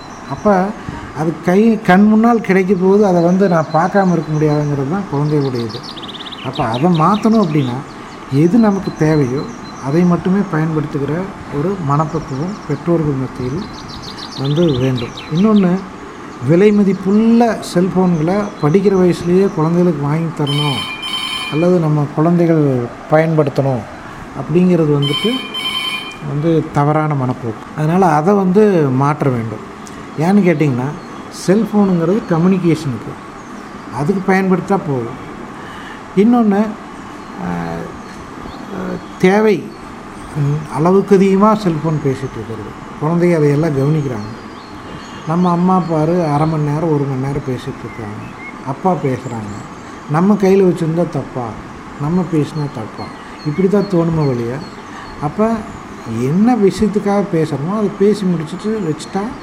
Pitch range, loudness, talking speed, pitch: 145-190 Hz, -15 LUFS, 105 wpm, 160 Hz